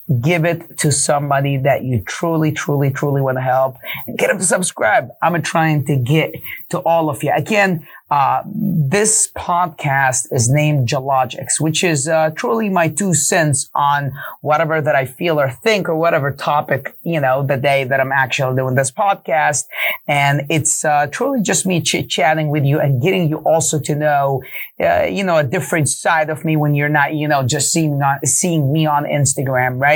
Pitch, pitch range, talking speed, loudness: 150 Hz, 140-165 Hz, 190 wpm, -16 LUFS